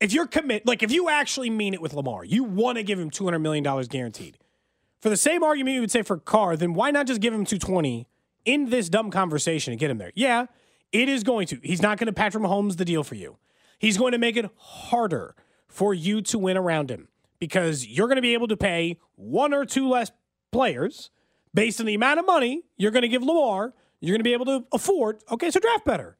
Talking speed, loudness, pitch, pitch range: 240 wpm, -24 LUFS, 215 Hz, 180-255 Hz